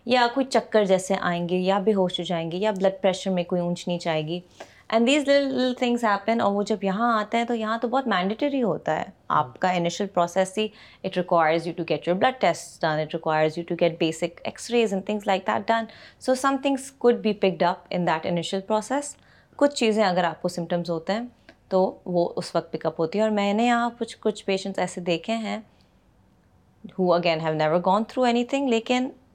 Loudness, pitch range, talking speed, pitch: -24 LUFS, 175-230 Hz, 230 wpm, 195 Hz